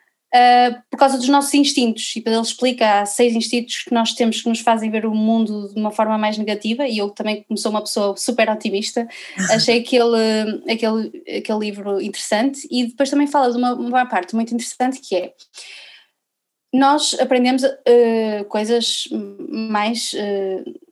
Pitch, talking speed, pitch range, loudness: 230 Hz, 170 wpm, 215-255 Hz, -18 LUFS